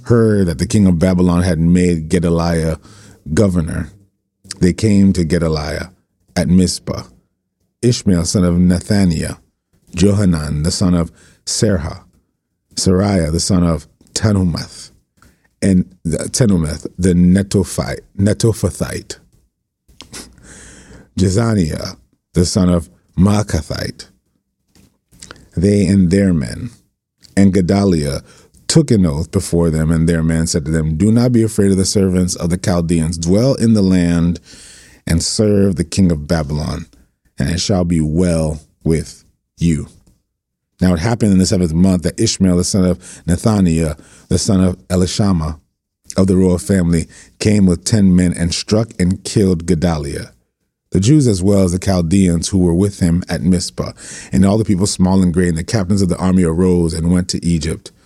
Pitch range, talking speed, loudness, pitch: 85-100 Hz, 150 wpm, -15 LUFS, 90 Hz